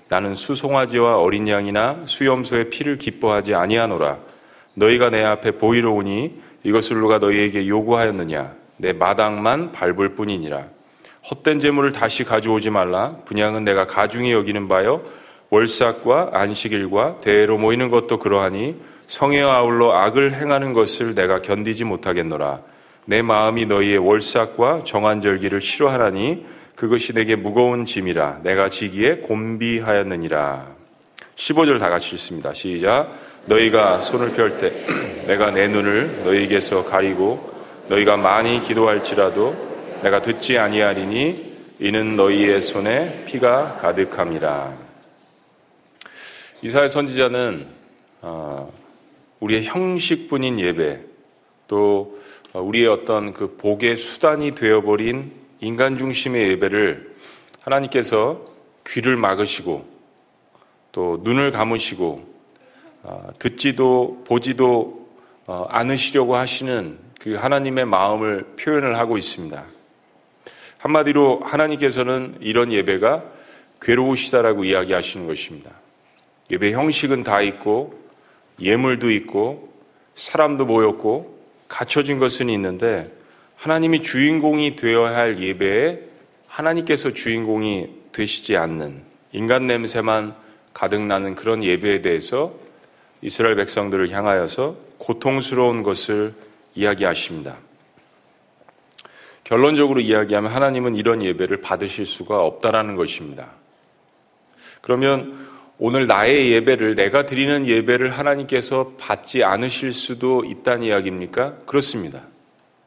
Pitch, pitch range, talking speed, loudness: 115 Hz, 105-130 Hz, 285 characters per minute, -19 LUFS